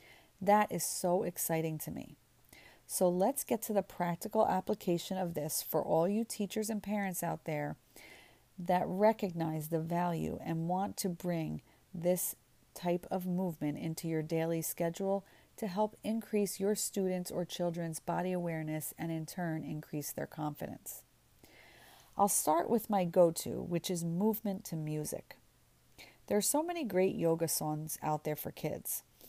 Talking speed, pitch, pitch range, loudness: 155 wpm, 175 Hz, 160-200 Hz, -35 LUFS